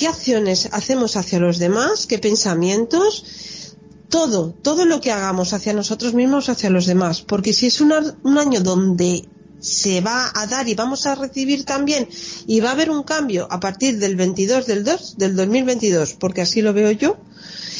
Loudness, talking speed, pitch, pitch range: -18 LUFS, 180 wpm, 220 Hz, 190-275 Hz